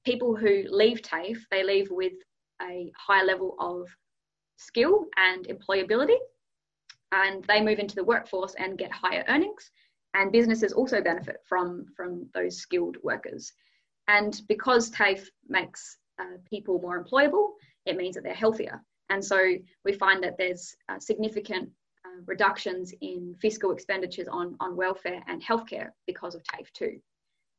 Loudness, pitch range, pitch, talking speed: -27 LUFS, 185-230 Hz, 195 Hz, 150 wpm